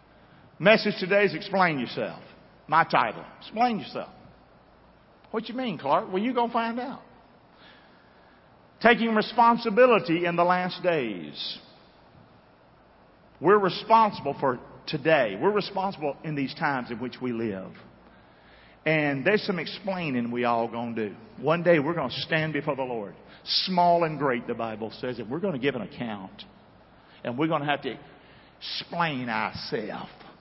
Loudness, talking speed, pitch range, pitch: -26 LUFS, 150 wpm, 135-205 Hz, 170 Hz